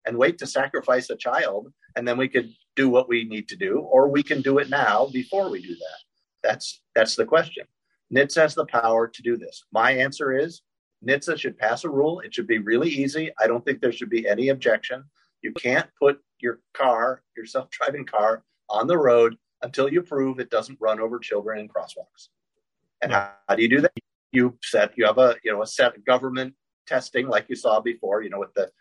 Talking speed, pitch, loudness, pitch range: 220 wpm, 130 Hz, -23 LUFS, 115-145 Hz